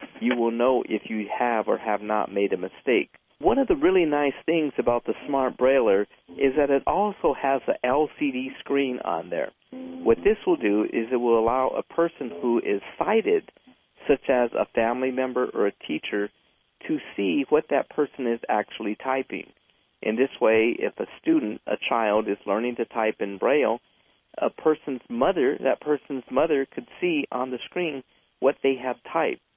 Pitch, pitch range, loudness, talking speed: 135 Hz, 120-170 Hz, -25 LUFS, 185 wpm